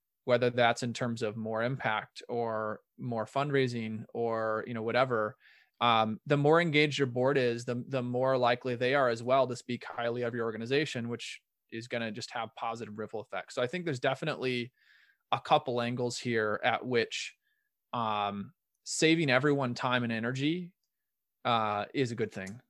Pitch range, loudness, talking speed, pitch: 115-135 Hz, -31 LUFS, 175 wpm, 120 Hz